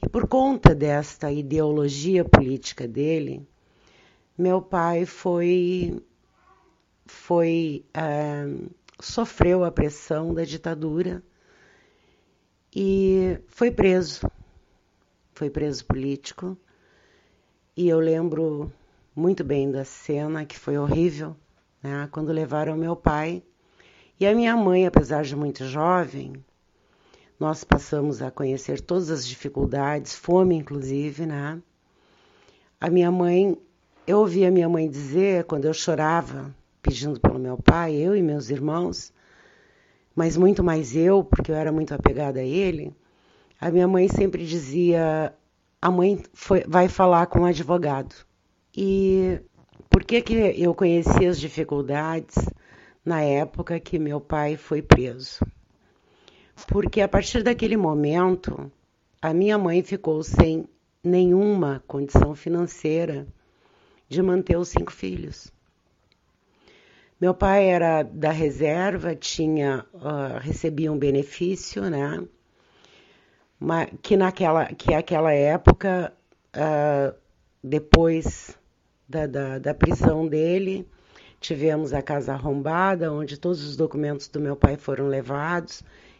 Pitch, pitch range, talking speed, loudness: 160 Hz, 145-180 Hz, 120 wpm, -23 LUFS